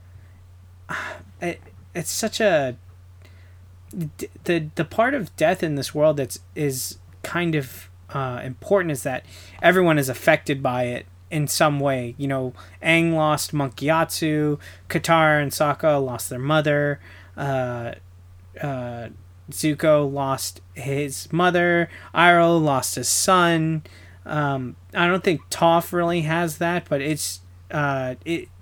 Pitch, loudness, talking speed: 140 Hz, -22 LUFS, 130 wpm